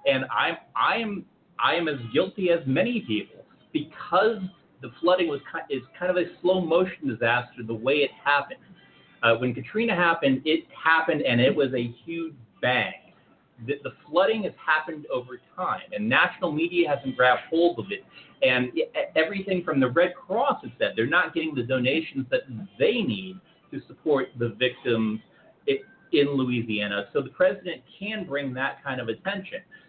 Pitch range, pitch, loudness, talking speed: 125-185 Hz, 155 Hz, -25 LUFS, 170 wpm